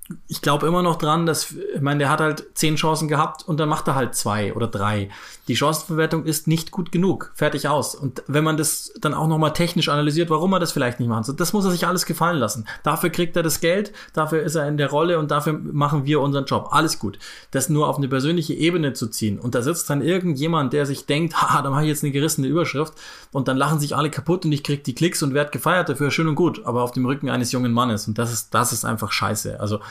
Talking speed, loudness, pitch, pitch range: 260 wpm, -21 LUFS, 150 Hz, 135-160 Hz